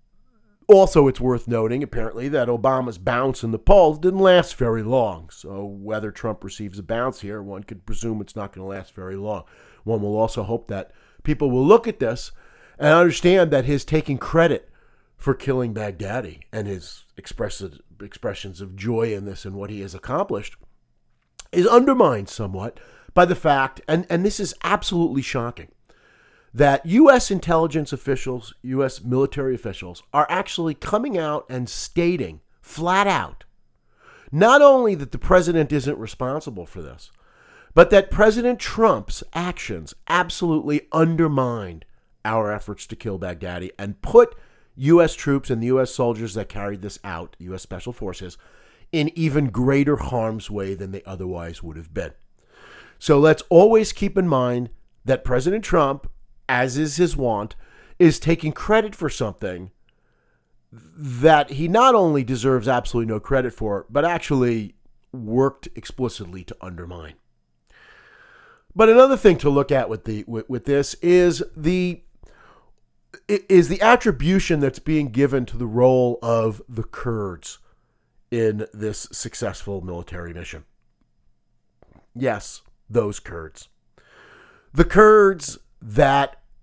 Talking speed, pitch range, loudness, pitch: 145 wpm, 105-165 Hz, -20 LUFS, 125 Hz